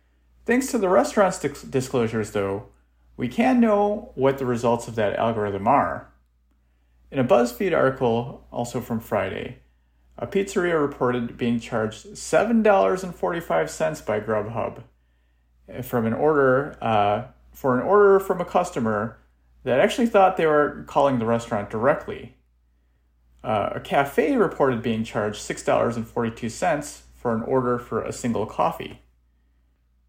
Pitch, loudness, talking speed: 115 Hz, -23 LUFS, 130 wpm